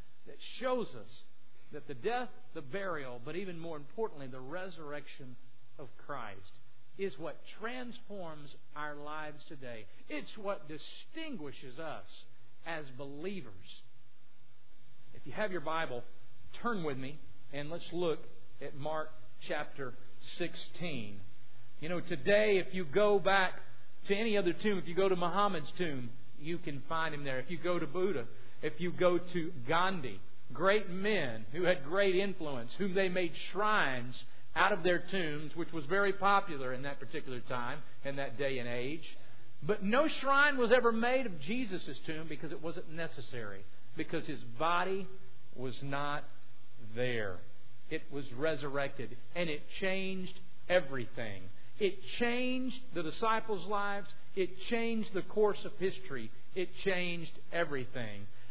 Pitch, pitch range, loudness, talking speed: 155 Hz, 130-190 Hz, -36 LUFS, 145 wpm